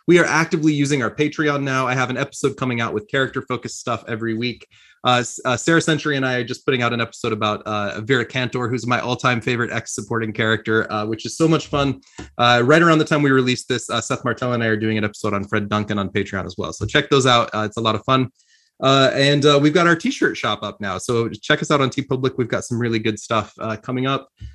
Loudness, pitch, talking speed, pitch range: -19 LUFS, 125 Hz, 260 wpm, 110-140 Hz